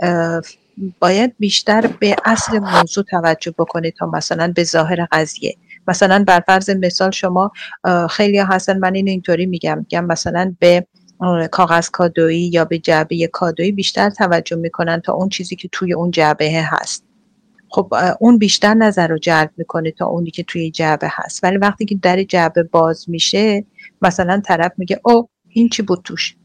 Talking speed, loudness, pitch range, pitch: 165 wpm, -15 LUFS, 170-200 Hz, 180 Hz